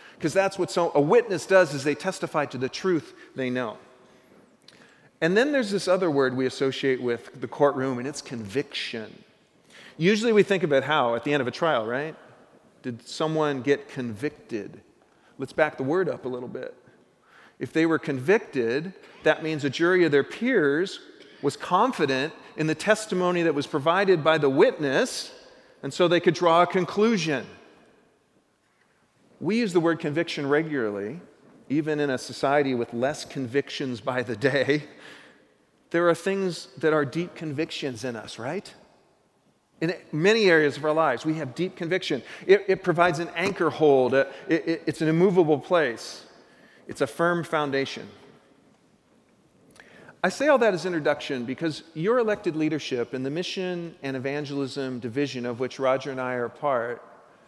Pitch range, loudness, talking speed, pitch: 135-180 Hz, -25 LUFS, 165 wpm, 155 Hz